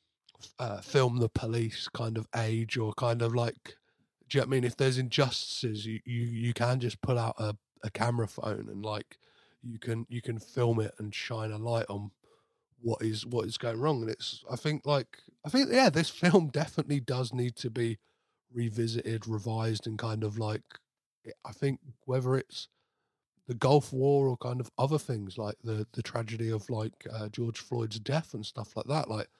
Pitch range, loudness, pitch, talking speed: 110-130 Hz, -32 LUFS, 115 Hz, 200 wpm